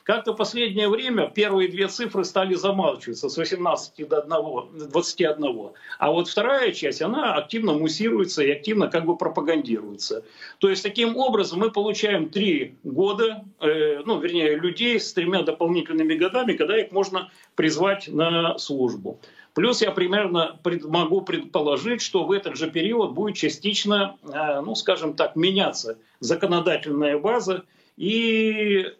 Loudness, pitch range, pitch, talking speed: -23 LUFS, 160-220 Hz, 190 Hz, 145 wpm